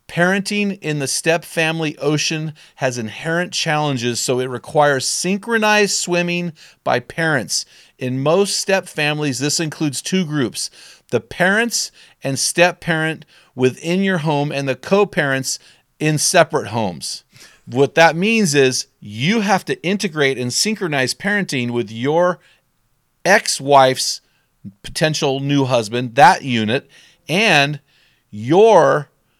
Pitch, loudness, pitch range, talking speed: 150 Hz, -17 LUFS, 135-175 Hz, 125 wpm